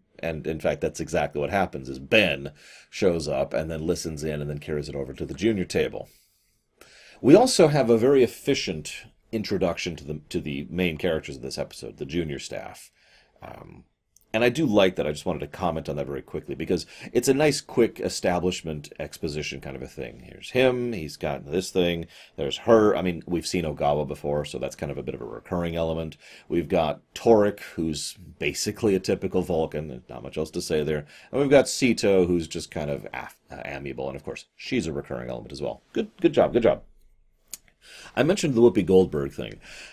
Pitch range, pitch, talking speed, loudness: 75-95 Hz, 80 Hz, 205 wpm, -25 LUFS